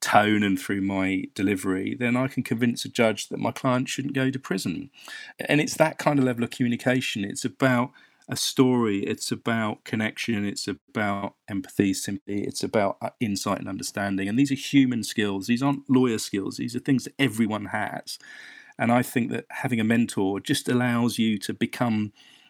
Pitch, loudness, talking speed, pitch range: 115 Hz, -25 LUFS, 185 wpm, 100-130 Hz